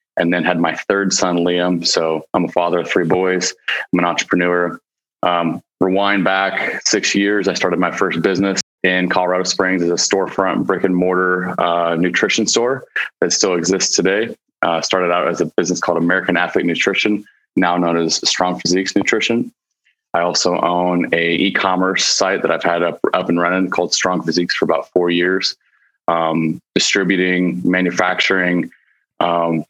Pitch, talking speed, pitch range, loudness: 90 Hz, 170 wpm, 85-95 Hz, -16 LUFS